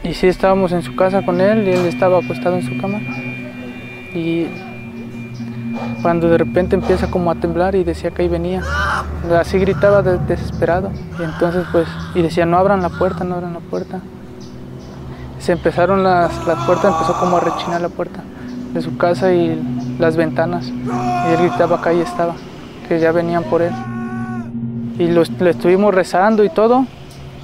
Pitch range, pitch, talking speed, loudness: 125-180 Hz, 170 Hz, 175 wpm, -16 LUFS